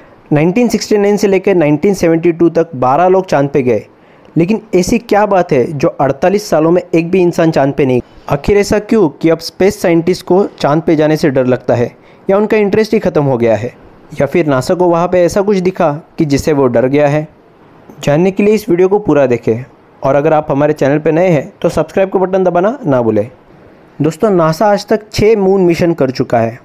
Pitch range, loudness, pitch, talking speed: 145-195 Hz, -11 LUFS, 170 Hz, 220 wpm